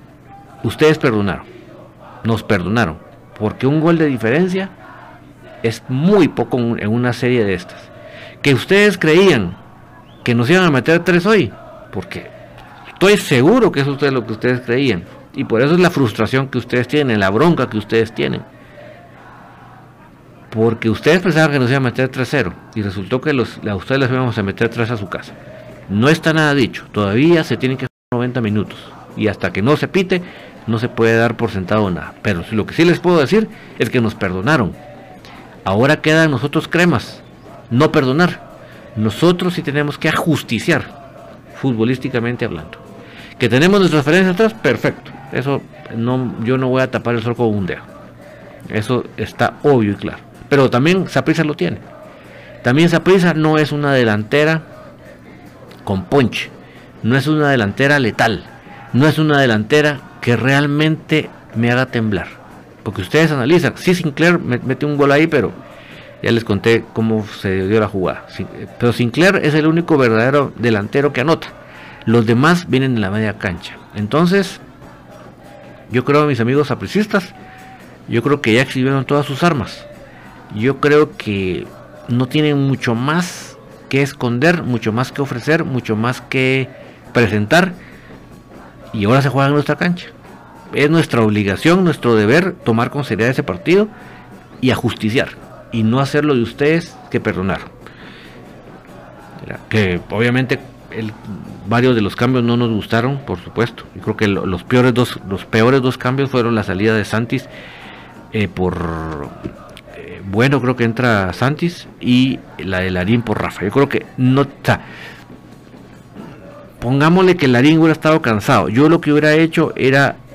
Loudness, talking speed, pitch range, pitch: -15 LUFS, 160 wpm, 110-150 Hz, 130 Hz